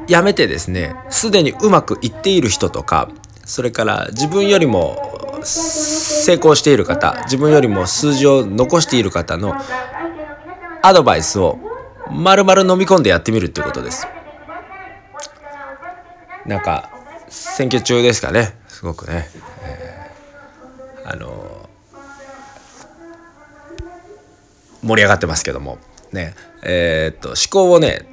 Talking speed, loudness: 250 characters per minute, -14 LUFS